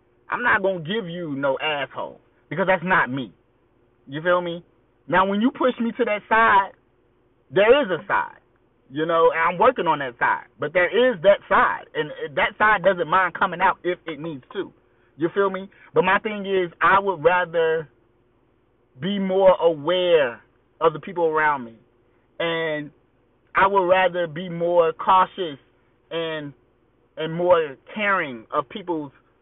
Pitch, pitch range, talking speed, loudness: 165 Hz, 125-195 Hz, 165 wpm, -21 LUFS